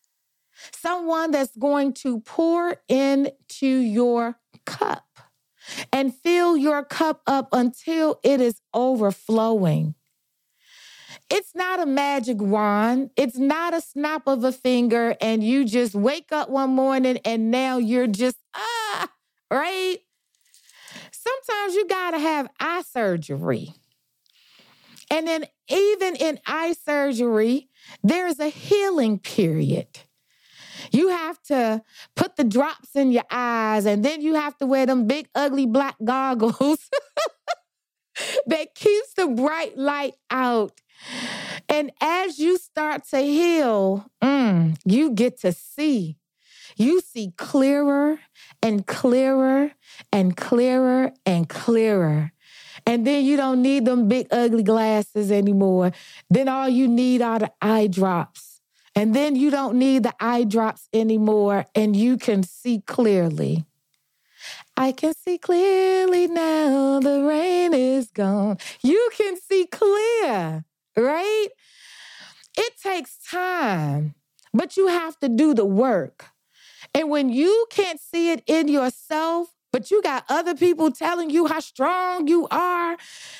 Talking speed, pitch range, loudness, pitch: 130 wpm, 225-320 Hz, -22 LUFS, 270 Hz